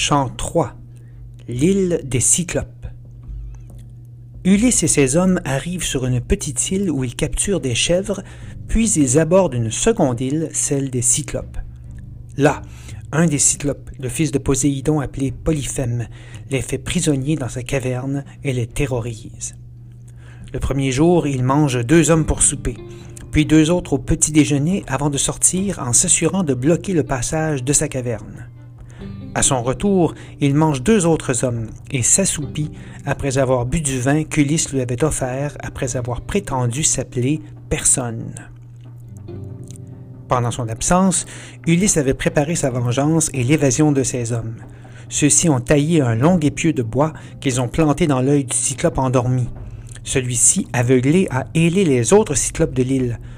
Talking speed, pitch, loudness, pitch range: 150 wpm, 135 Hz, -18 LUFS, 120-155 Hz